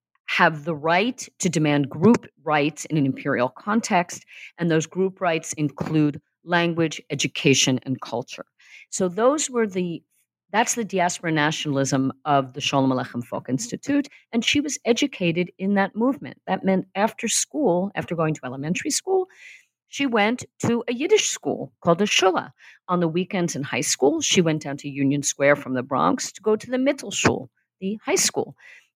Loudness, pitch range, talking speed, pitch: -23 LUFS, 150-220 Hz, 170 wpm, 175 Hz